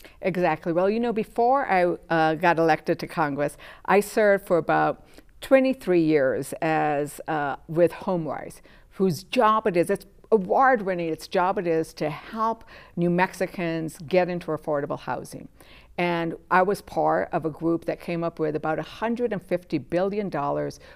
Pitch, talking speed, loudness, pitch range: 175 Hz, 155 wpm, -24 LUFS, 160-195 Hz